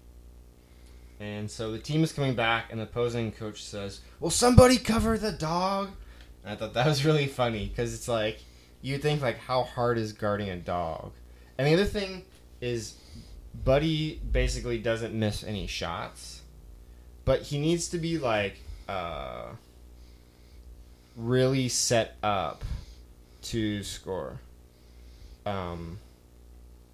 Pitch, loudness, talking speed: 105 Hz, -28 LUFS, 135 wpm